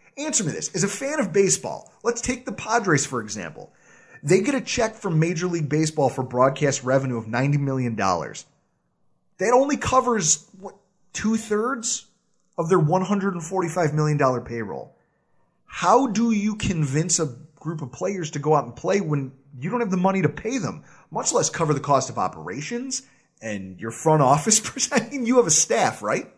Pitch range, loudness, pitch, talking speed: 145-225 Hz, -22 LUFS, 180 Hz, 175 wpm